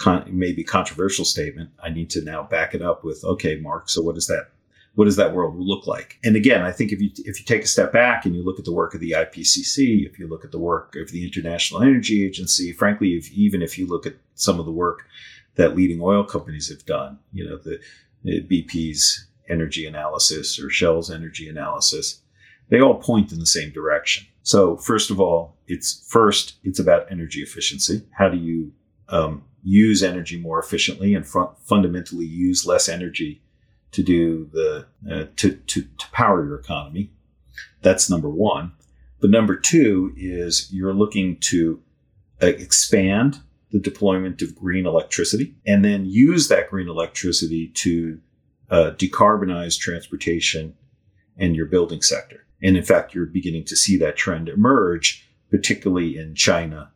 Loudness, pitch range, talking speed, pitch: -20 LUFS, 80-100 Hz, 175 wpm, 90 Hz